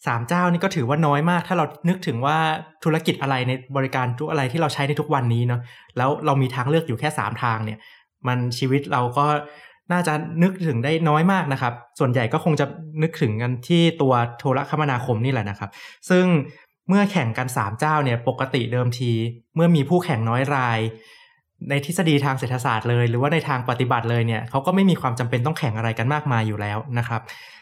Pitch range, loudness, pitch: 120-155 Hz, -22 LUFS, 140 Hz